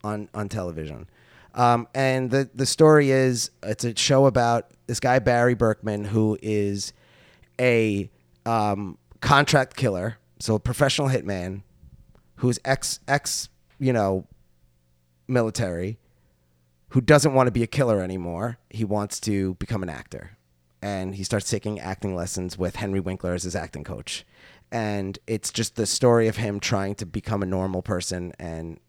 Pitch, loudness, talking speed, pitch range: 105 Hz, -24 LUFS, 155 wpm, 90-120 Hz